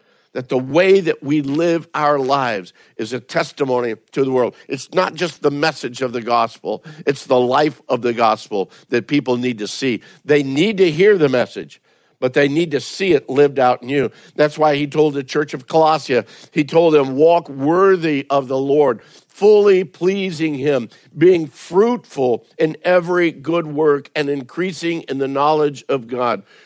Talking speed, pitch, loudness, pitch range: 180 wpm, 150 Hz, -17 LUFS, 135-170 Hz